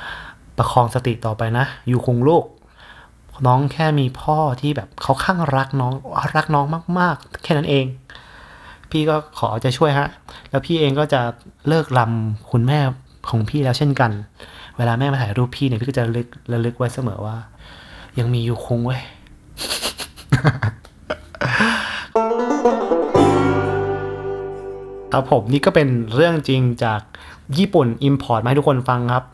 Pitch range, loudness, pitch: 115-145 Hz, -19 LUFS, 130 Hz